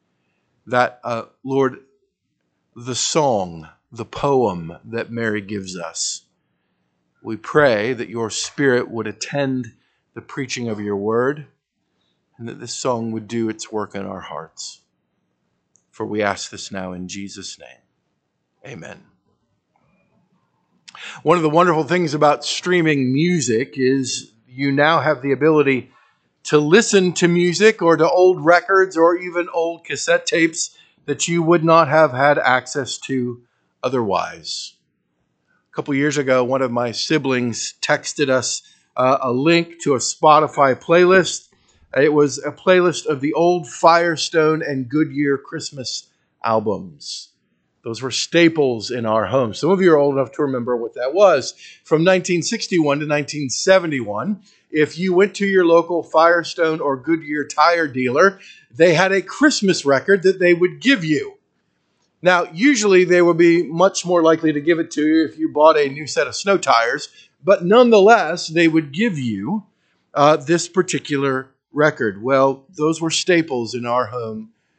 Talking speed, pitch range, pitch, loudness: 150 wpm, 125-175 Hz, 150 Hz, -17 LUFS